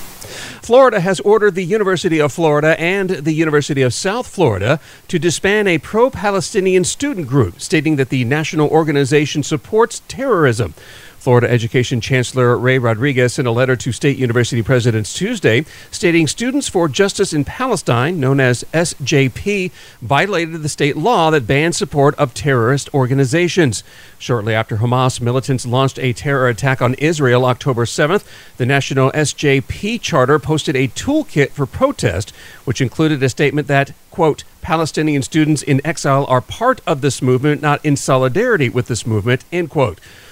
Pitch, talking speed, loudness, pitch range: 145 Hz, 155 wpm, -15 LUFS, 130-170 Hz